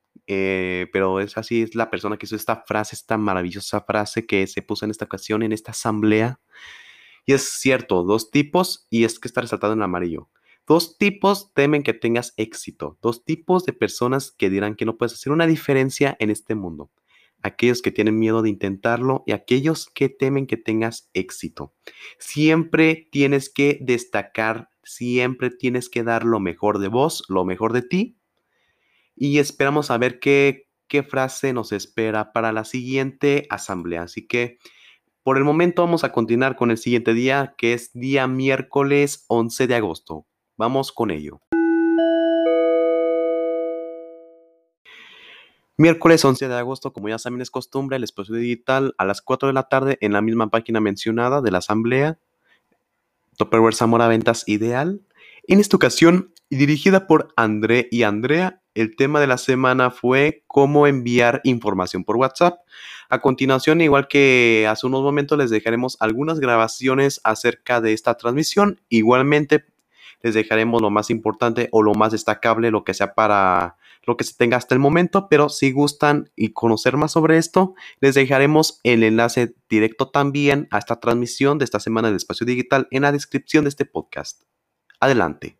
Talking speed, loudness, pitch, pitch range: 165 wpm, -19 LUFS, 125 Hz, 110-145 Hz